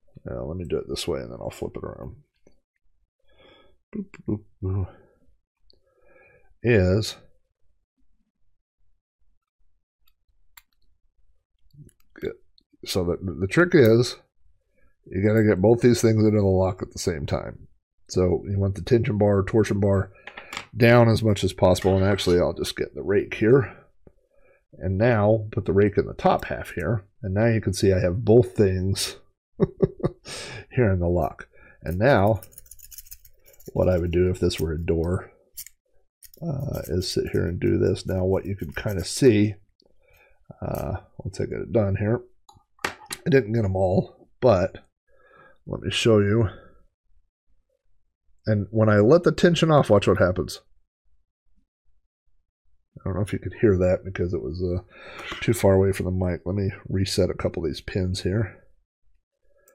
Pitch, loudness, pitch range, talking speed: 95 Hz, -23 LUFS, 90-110 Hz, 160 wpm